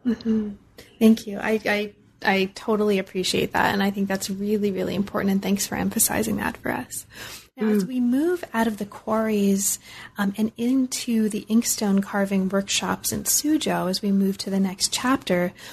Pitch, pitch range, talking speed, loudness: 205 Hz, 195-225 Hz, 180 wpm, -23 LUFS